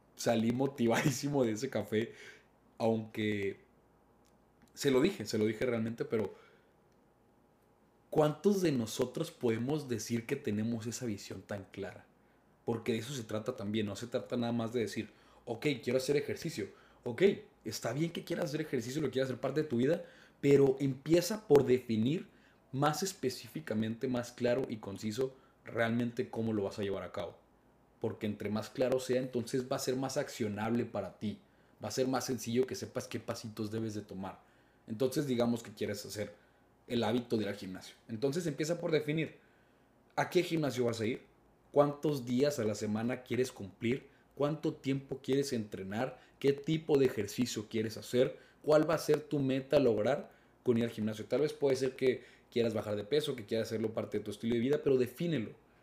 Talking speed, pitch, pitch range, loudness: 180 wpm, 125 Hz, 110-140 Hz, -34 LUFS